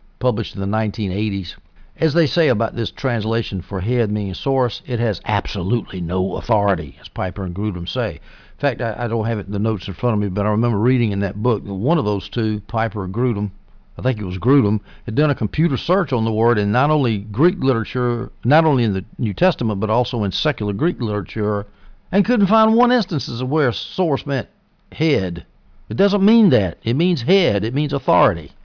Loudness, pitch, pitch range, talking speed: -19 LUFS, 115 Hz, 100-135 Hz, 215 wpm